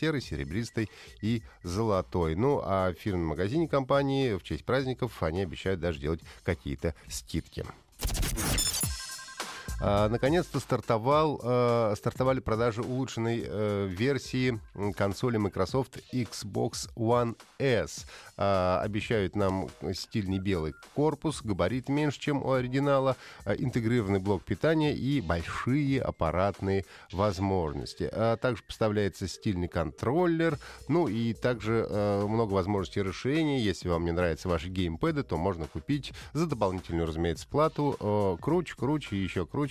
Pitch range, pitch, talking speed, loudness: 95-130 Hz, 105 Hz, 125 wpm, -30 LUFS